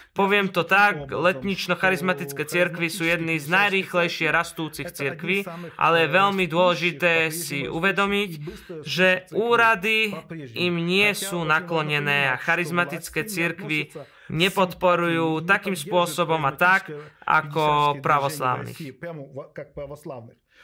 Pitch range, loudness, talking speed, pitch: 155-185 Hz, -22 LUFS, 95 wpm, 170 Hz